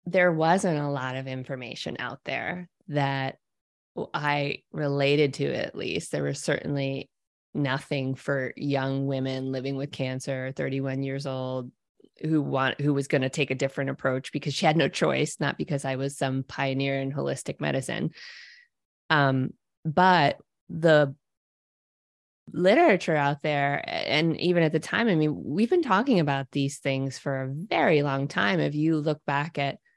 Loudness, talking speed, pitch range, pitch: -26 LUFS, 160 wpm, 135-155 Hz, 140 Hz